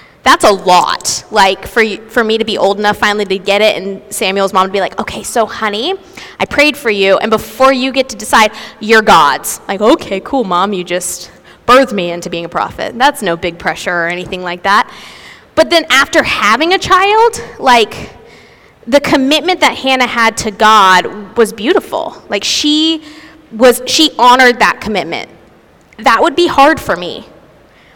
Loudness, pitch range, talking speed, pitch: -11 LUFS, 195-275 Hz, 180 wpm, 220 Hz